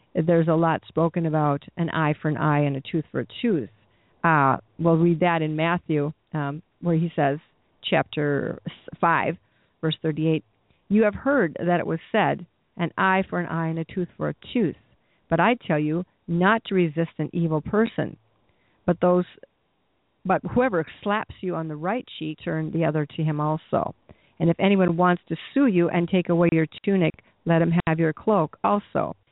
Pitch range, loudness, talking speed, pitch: 155-180 Hz, -24 LUFS, 190 wpm, 165 Hz